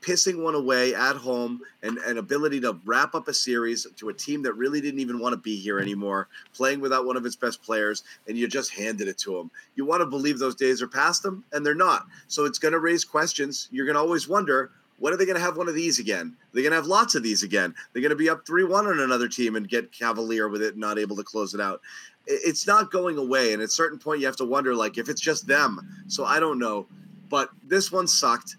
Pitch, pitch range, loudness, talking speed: 140 Hz, 120-175 Hz, -25 LUFS, 265 wpm